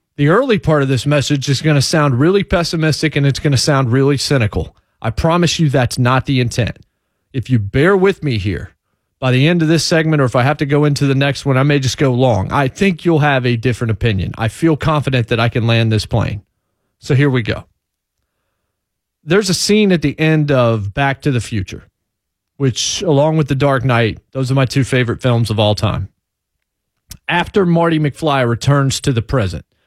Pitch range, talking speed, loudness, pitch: 115-150 Hz, 215 wpm, -15 LUFS, 135 Hz